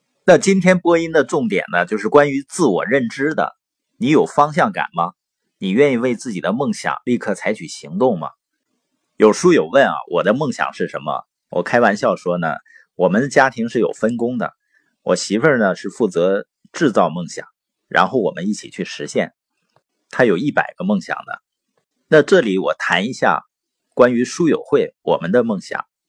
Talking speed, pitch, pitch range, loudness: 260 characters per minute, 145 Hz, 120-195 Hz, -17 LUFS